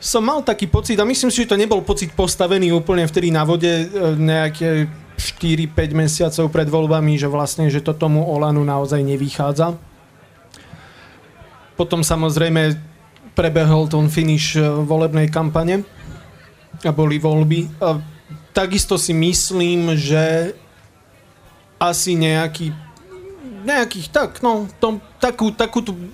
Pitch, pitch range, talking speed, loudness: 165 Hz, 155-190 Hz, 120 wpm, -18 LUFS